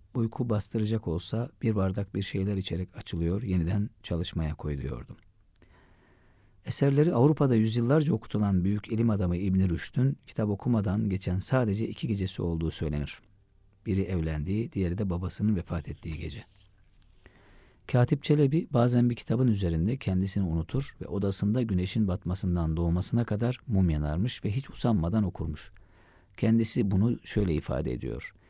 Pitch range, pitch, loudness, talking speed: 90-115 Hz, 100 Hz, -28 LUFS, 130 wpm